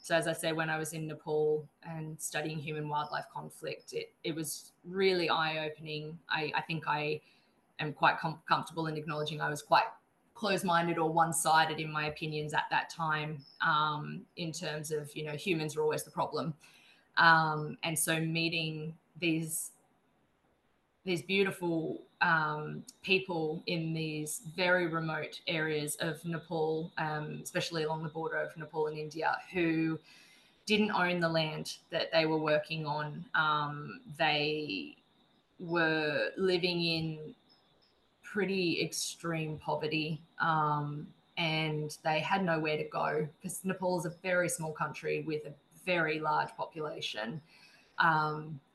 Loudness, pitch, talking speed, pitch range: -33 LUFS, 160 Hz, 145 wpm, 155-170 Hz